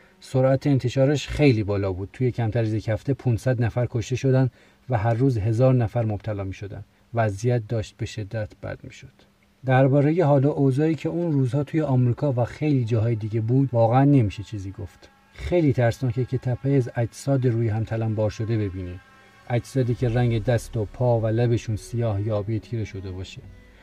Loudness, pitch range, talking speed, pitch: -23 LUFS, 110-130 Hz, 175 wpm, 120 Hz